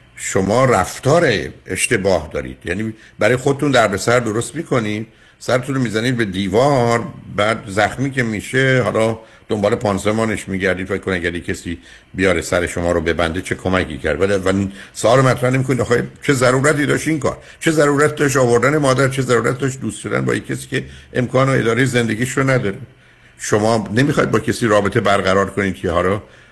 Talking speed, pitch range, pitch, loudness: 170 wpm, 100-130 Hz, 115 Hz, -17 LUFS